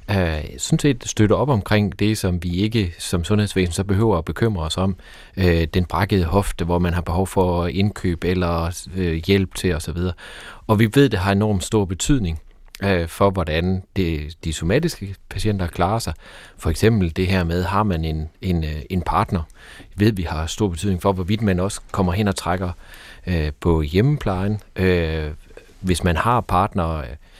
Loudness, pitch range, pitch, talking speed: -21 LUFS, 85-100 Hz, 95 Hz, 165 wpm